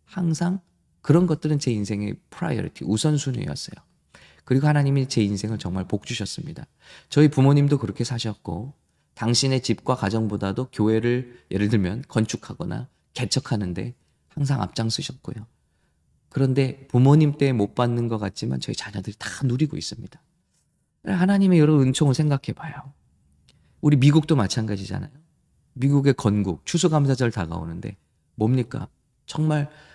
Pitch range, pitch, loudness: 105-145 Hz, 125 Hz, -23 LUFS